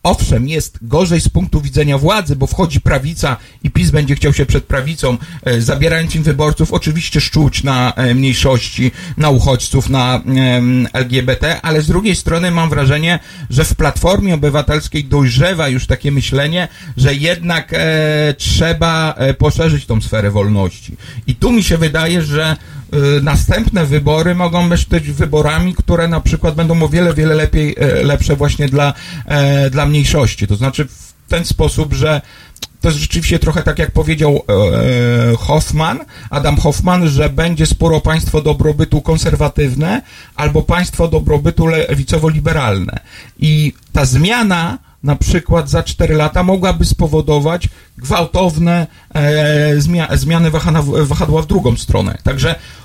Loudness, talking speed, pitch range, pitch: -13 LUFS, 135 wpm, 130-160 Hz, 150 Hz